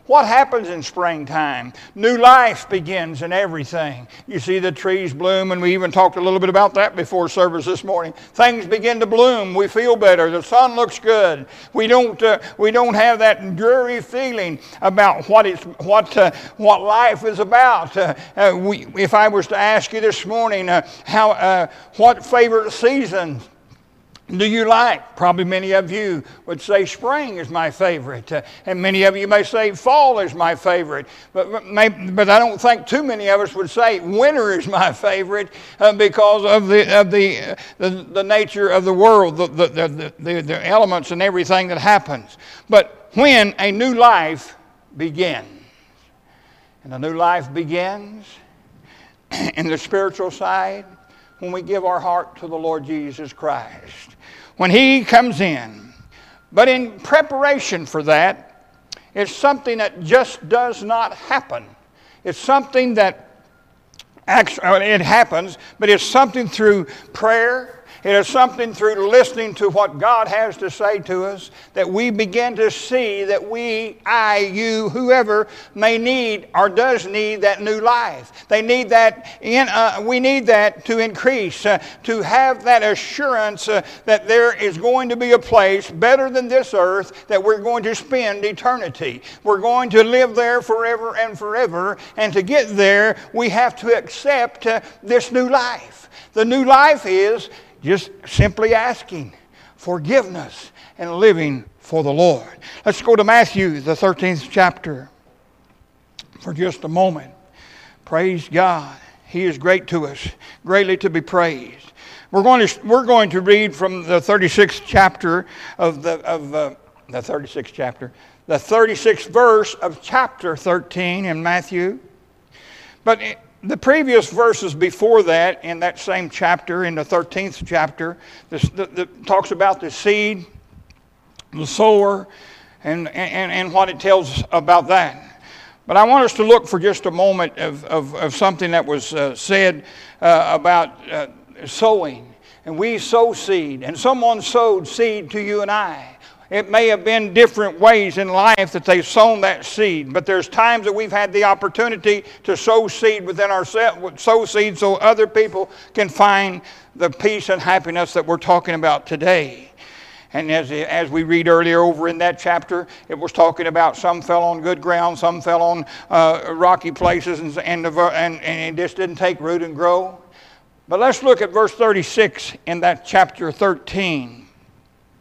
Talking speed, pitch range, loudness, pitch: 165 wpm, 175-225 Hz, -16 LUFS, 200 Hz